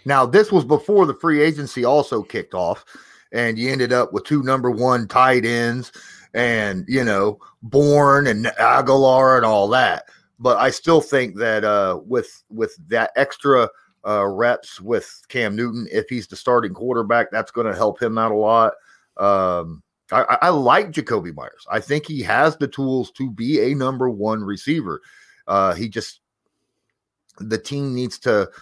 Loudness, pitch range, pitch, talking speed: -19 LUFS, 115-135 Hz, 125 Hz, 170 wpm